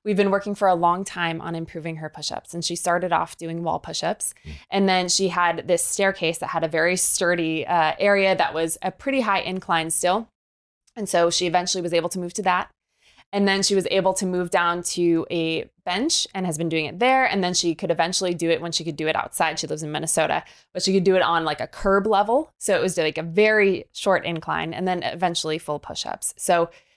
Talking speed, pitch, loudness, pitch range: 235 wpm, 175 Hz, -22 LUFS, 165-195 Hz